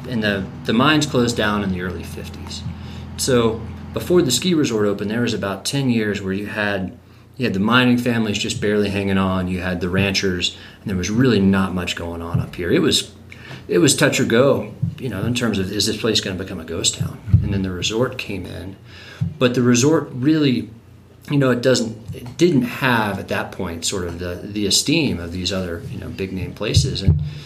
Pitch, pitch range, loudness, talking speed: 105 Hz, 95-120 Hz, -19 LUFS, 220 wpm